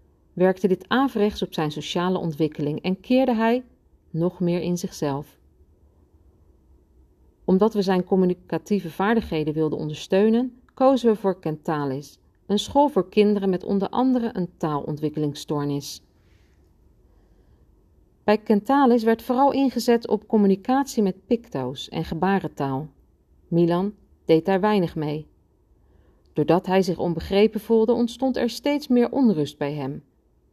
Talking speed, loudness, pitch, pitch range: 120 wpm, -23 LUFS, 180 Hz, 145-215 Hz